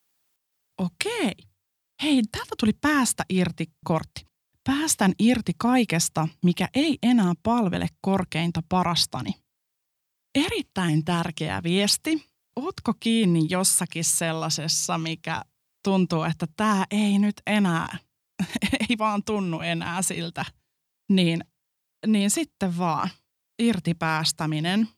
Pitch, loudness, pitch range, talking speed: 185 Hz, -24 LUFS, 165-225 Hz, 95 wpm